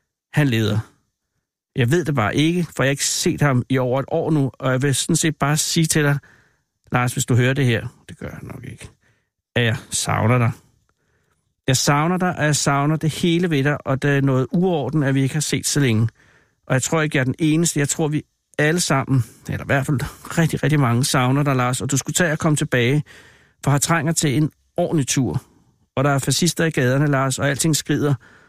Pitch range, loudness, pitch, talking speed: 130-155 Hz, -19 LUFS, 140 Hz, 235 wpm